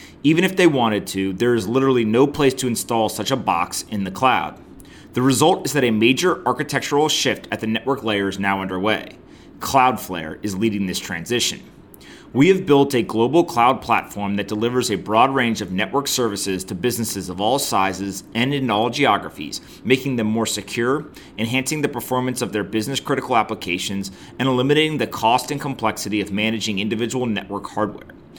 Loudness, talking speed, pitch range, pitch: -20 LUFS, 180 wpm, 100-130 Hz, 115 Hz